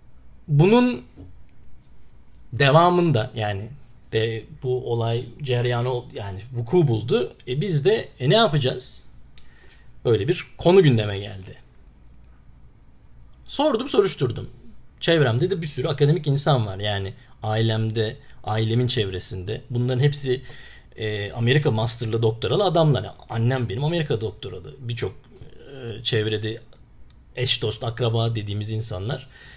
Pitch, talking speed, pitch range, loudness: 120 Hz, 110 wpm, 110-140 Hz, -23 LUFS